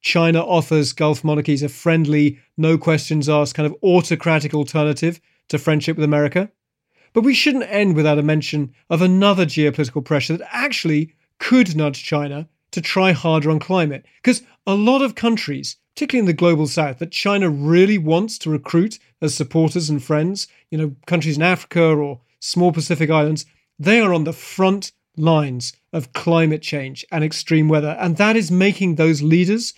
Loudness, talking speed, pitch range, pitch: -18 LUFS, 170 wpm, 150-180 Hz, 160 Hz